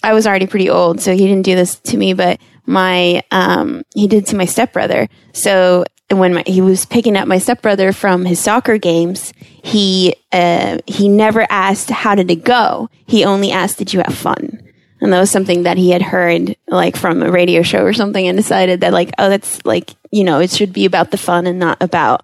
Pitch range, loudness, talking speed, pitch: 180-210 Hz, -13 LUFS, 225 wpm, 190 Hz